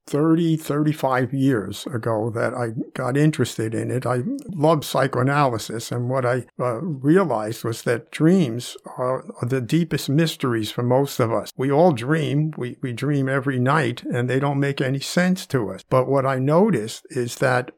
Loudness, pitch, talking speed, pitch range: -22 LUFS, 135 Hz, 175 wpm, 125-150 Hz